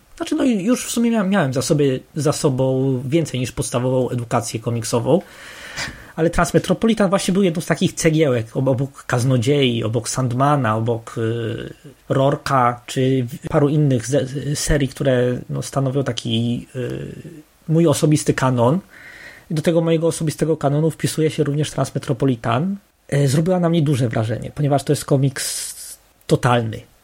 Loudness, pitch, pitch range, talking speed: -19 LUFS, 145 Hz, 125-165 Hz, 135 wpm